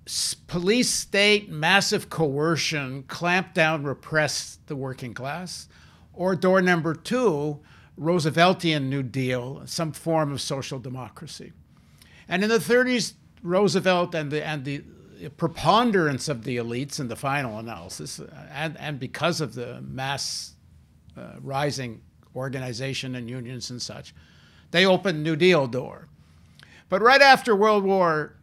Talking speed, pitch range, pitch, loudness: 130 wpm, 130-175 Hz, 150 Hz, -23 LUFS